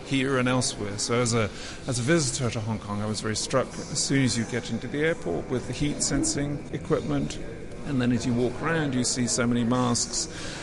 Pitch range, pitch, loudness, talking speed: 115-135 Hz, 125 Hz, -26 LUFS, 225 wpm